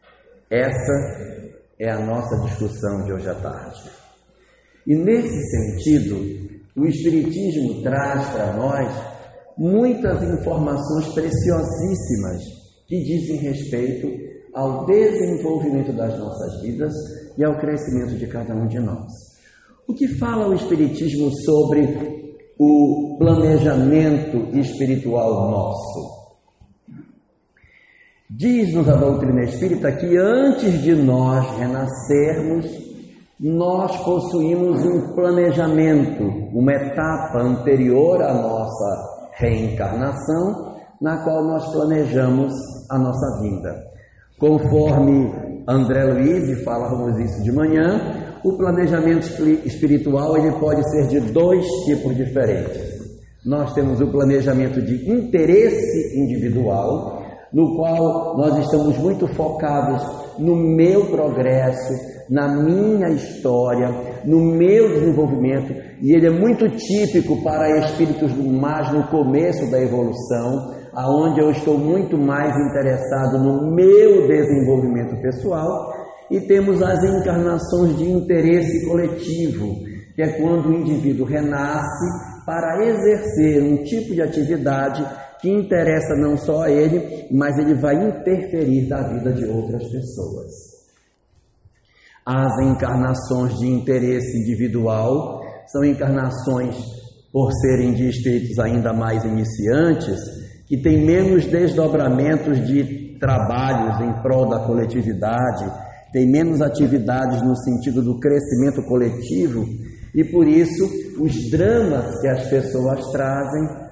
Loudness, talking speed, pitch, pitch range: -19 LUFS, 110 wpm, 140 Hz, 125-160 Hz